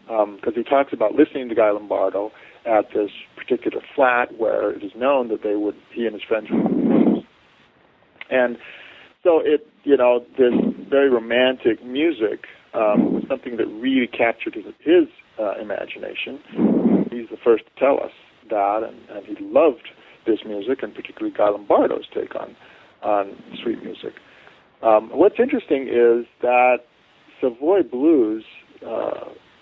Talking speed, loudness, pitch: 160 wpm, -20 LUFS, 150 Hz